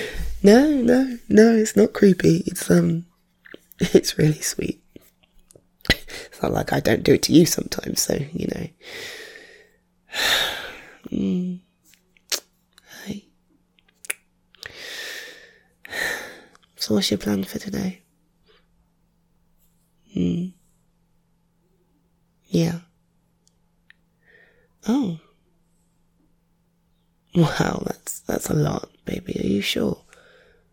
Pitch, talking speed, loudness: 175 Hz, 85 wpm, -21 LUFS